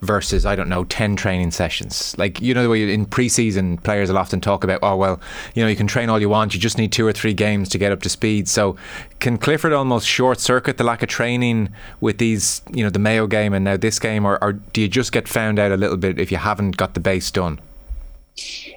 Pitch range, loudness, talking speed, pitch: 95-115 Hz, -19 LUFS, 255 wpm, 105 Hz